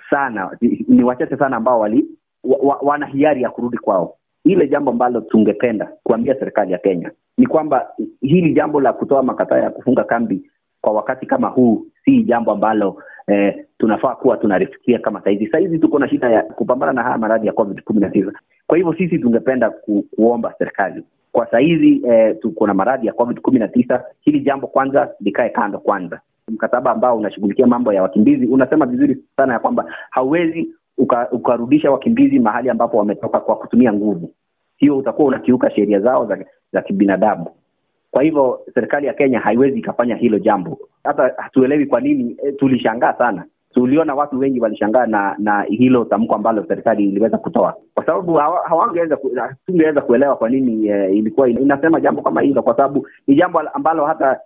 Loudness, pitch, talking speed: -16 LUFS, 140 Hz, 170 wpm